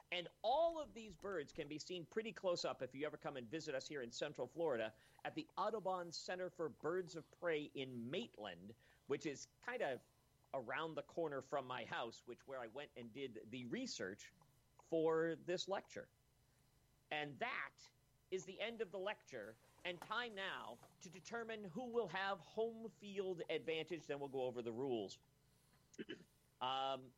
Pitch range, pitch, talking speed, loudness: 135-190 Hz, 160 Hz, 175 wpm, -46 LUFS